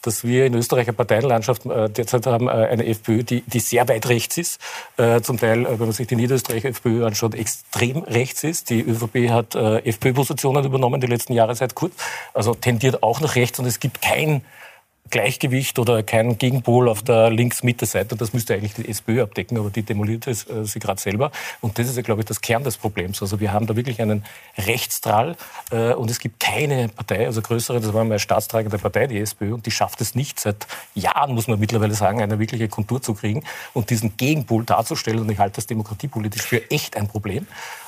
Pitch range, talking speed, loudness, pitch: 110-125 Hz, 205 wpm, -21 LUFS, 115 Hz